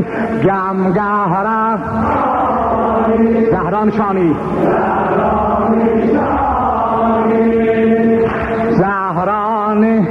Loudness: -14 LUFS